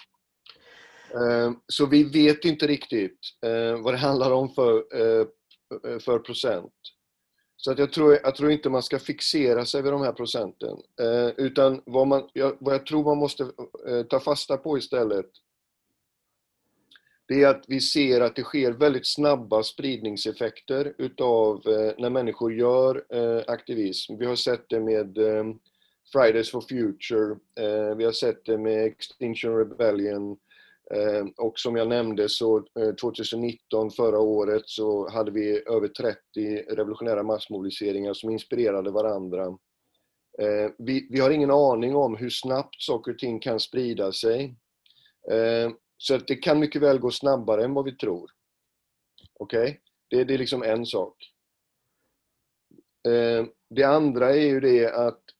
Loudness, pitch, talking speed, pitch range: -25 LUFS, 120 Hz, 135 wpm, 110-135 Hz